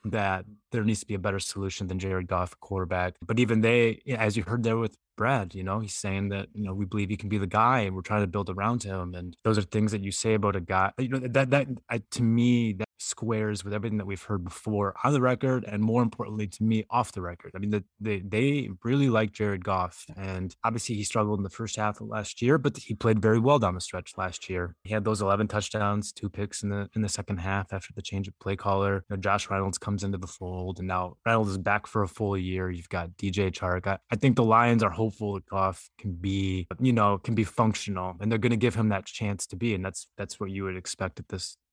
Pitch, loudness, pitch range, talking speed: 105 Hz, -28 LUFS, 95-110 Hz, 265 wpm